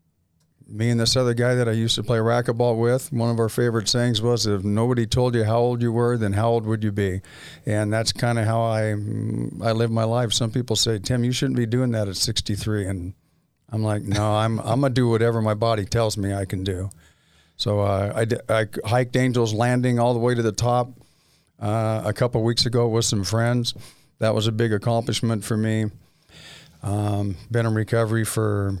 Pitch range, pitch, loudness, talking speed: 105-120 Hz, 115 Hz, -22 LUFS, 220 wpm